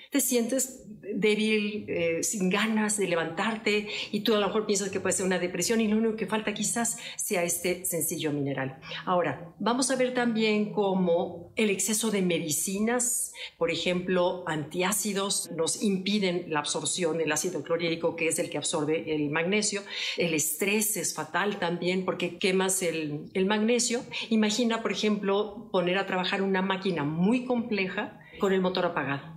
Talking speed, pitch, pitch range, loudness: 165 wpm, 190 Hz, 170-215 Hz, -27 LUFS